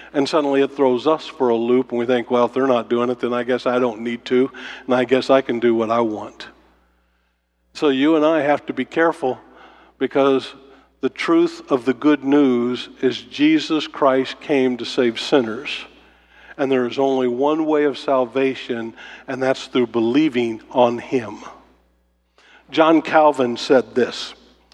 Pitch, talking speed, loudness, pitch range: 130 Hz, 175 wpm, -19 LUFS, 120-140 Hz